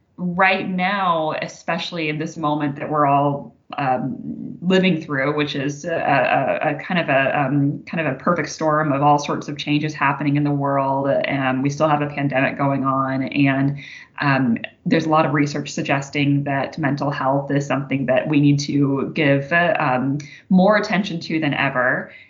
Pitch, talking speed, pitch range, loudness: 145 Hz, 185 wpm, 140-160 Hz, -20 LUFS